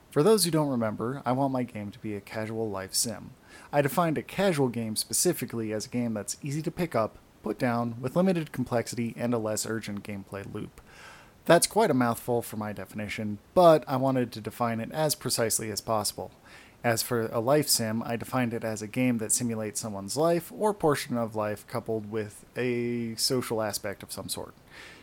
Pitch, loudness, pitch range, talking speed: 115 Hz, -28 LUFS, 110-130 Hz, 200 wpm